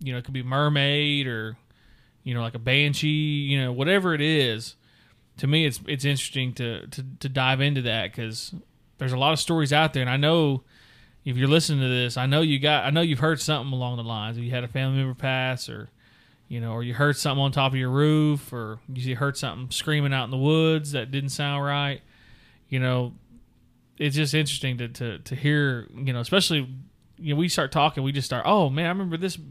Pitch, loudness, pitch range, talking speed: 135 Hz, -24 LUFS, 125-150 Hz, 230 wpm